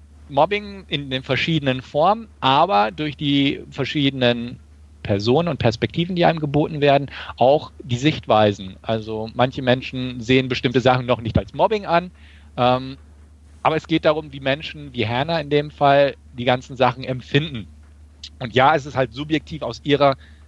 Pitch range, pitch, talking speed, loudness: 110-145 Hz, 130 Hz, 160 wpm, -20 LUFS